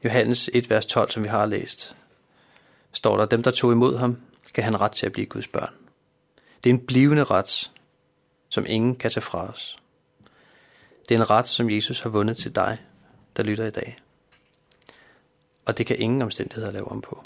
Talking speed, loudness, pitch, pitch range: 195 wpm, -23 LUFS, 115 Hz, 110-125 Hz